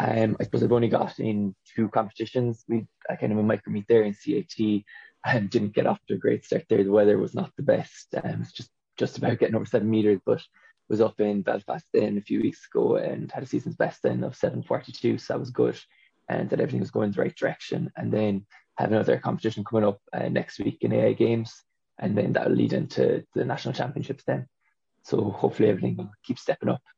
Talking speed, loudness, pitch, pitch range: 230 wpm, -26 LUFS, 105 Hz, 100-115 Hz